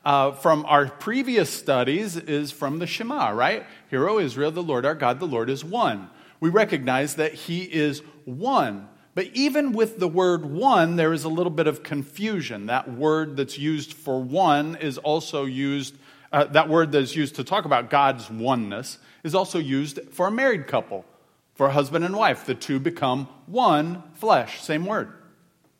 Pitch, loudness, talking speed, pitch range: 150 Hz, -23 LUFS, 180 wpm, 140-170 Hz